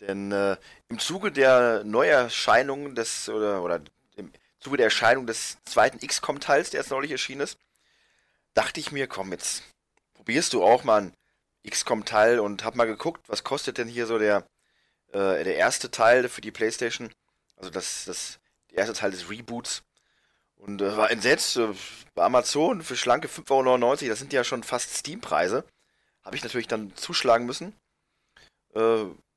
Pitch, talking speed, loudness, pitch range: 115 Hz, 165 wpm, -25 LUFS, 100-120 Hz